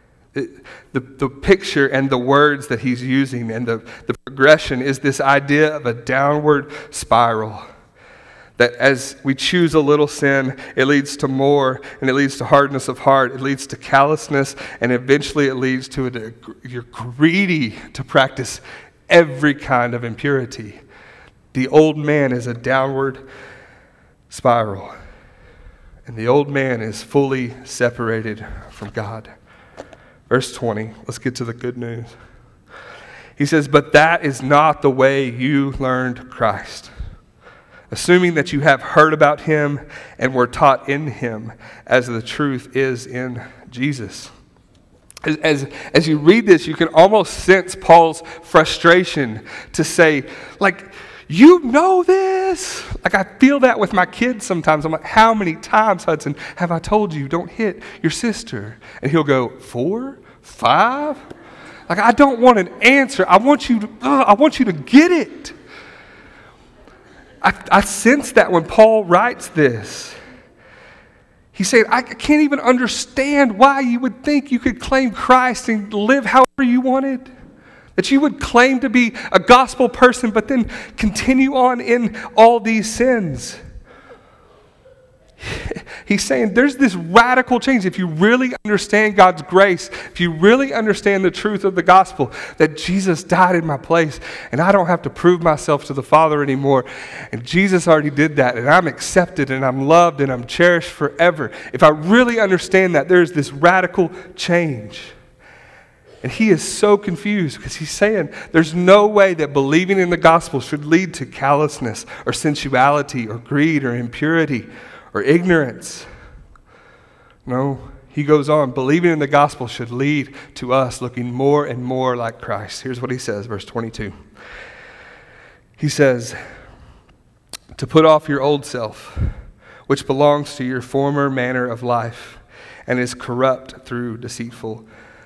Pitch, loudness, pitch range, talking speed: 150 Hz, -16 LUFS, 130-195 Hz, 155 wpm